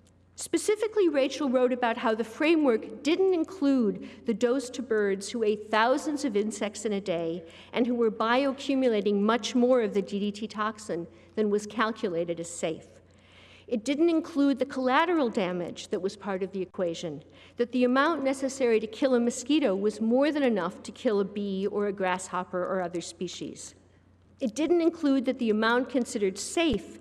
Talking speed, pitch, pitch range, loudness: 175 wpm, 225 Hz, 195-265 Hz, -28 LUFS